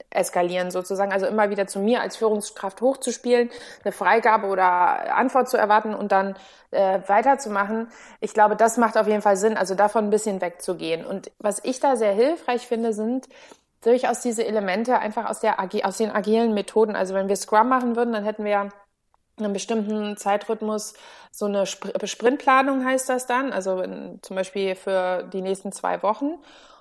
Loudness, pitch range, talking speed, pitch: -23 LUFS, 195-235 Hz, 175 wpm, 215 Hz